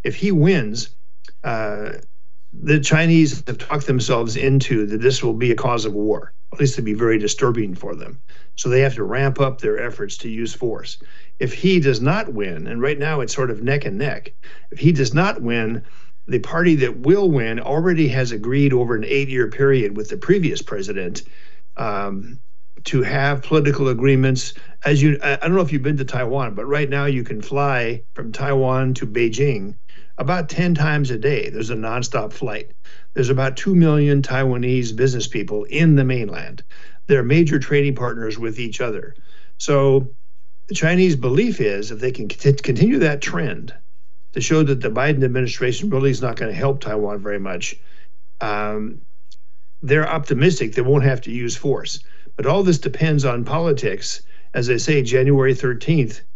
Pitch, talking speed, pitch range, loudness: 135 Hz, 180 wpm, 120-145 Hz, -19 LUFS